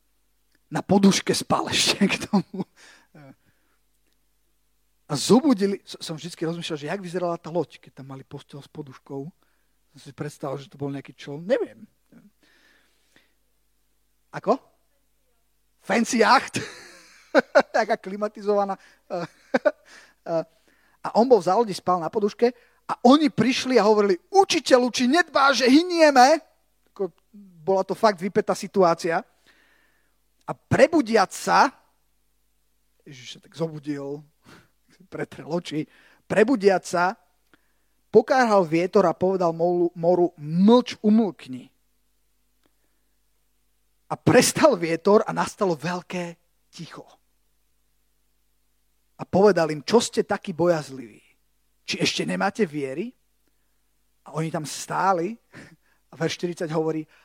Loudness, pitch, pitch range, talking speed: -22 LUFS, 185 Hz, 160-220 Hz, 110 wpm